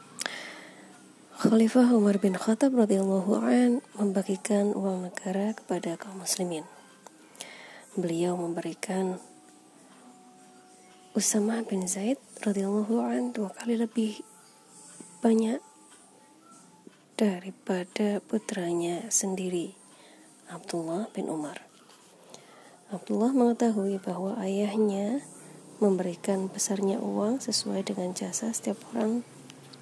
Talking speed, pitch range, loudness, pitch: 80 wpm, 185-225 Hz, -28 LUFS, 200 Hz